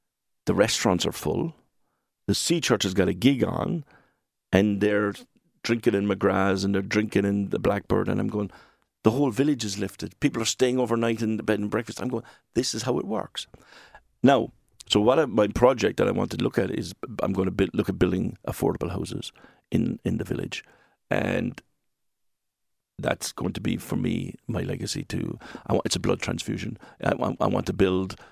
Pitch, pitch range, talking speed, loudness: 105 Hz, 100-120 Hz, 200 wpm, -26 LUFS